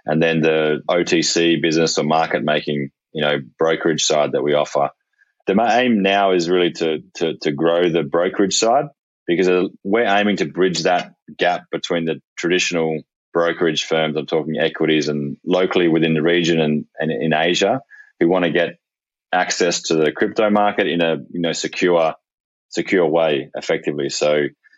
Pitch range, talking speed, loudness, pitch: 75-85 Hz, 165 wpm, -18 LUFS, 80 Hz